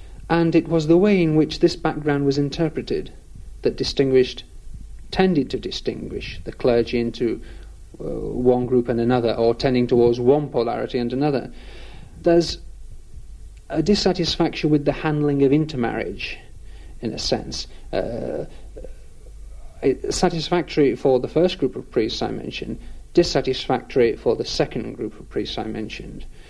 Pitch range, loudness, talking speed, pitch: 125-165 Hz, -21 LUFS, 140 wpm, 145 Hz